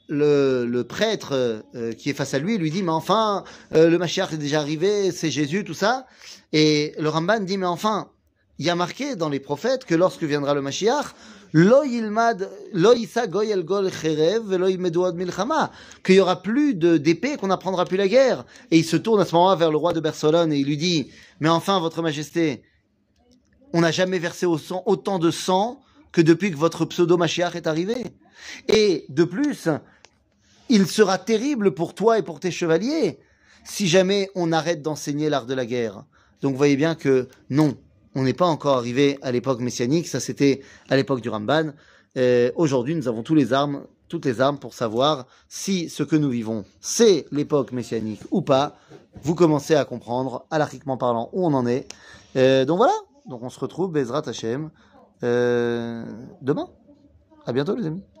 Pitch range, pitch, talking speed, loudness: 135-185 Hz, 160 Hz, 180 wpm, -22 LUFS